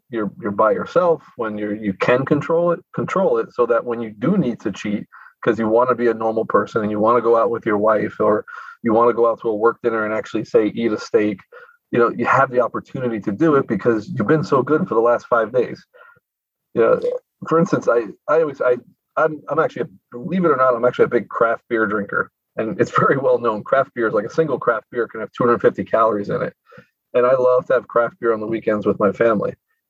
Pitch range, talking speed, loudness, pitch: 115-185 Hz, 255 wpm, -19 LUFS, 125 Hz